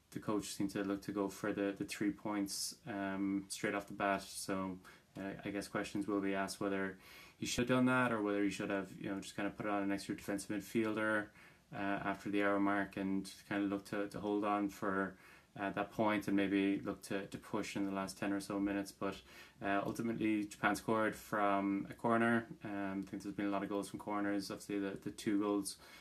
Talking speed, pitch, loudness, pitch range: 235 wpm, 100 Hz, -39 LUFS, 100-105 Hz